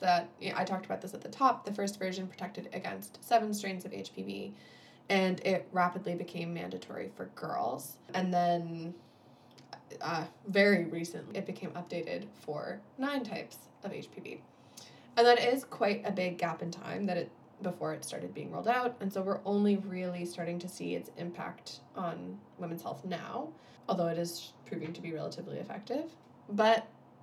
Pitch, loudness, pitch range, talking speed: 180 Hz, -34 LUFS, 170-200 Hz, 175 wpm